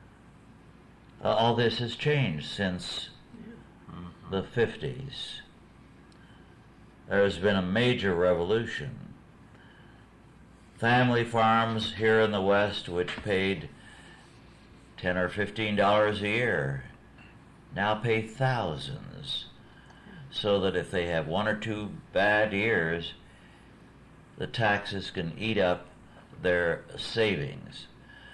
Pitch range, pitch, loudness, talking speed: 90-115 Hz, 105 Hz, -28 LUFS, 100 wpm